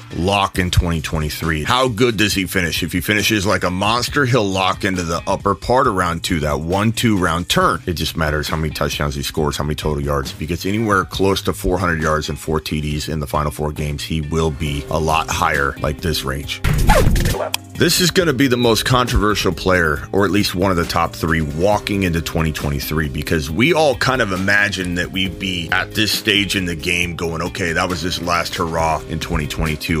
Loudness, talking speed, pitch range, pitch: -18 LUFS, 210 wpm, 80-100 Hz, 90 Hz